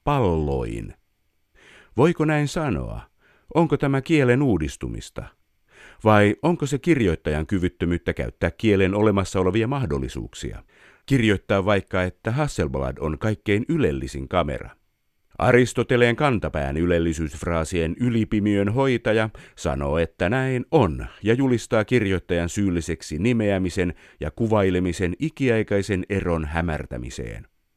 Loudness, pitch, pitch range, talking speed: -22 LUFS, 100 Hz, 85-125 Hz, 95 wpm